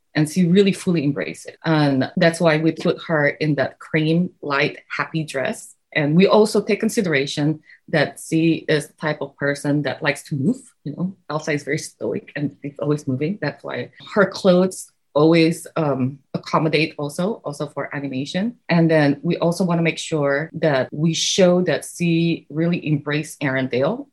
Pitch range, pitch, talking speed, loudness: 145-170 Hz, 155 Hz, 175 wpm, -20 LUFS